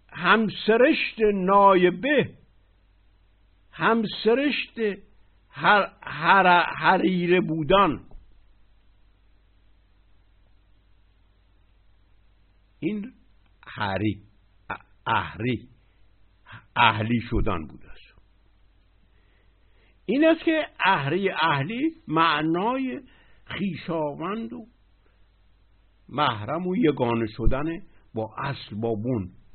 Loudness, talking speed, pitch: -23 LUFS, 60 wpm, 110 Hz